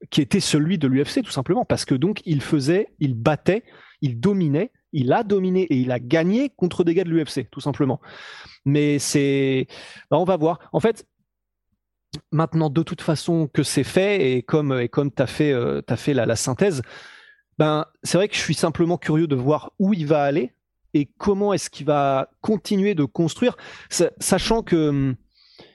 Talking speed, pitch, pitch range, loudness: 190 wpm, 155 Hz, 140-185 Hz, -21 LUFS